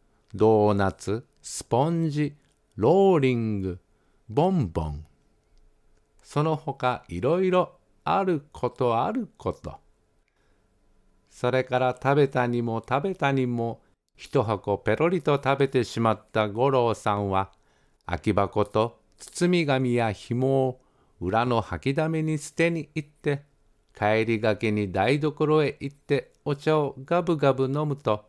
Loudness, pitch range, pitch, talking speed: -25 LUFS, 110-150 Hz, 130 Hz, 255 characters per minute